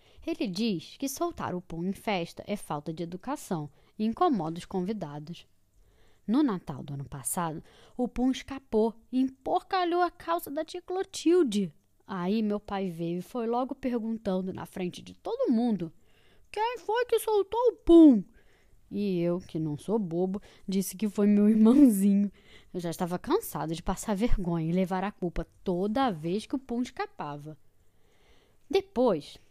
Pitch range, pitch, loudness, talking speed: 175-265 Hz, 205 Hz, -29 LUFS, 160 wpm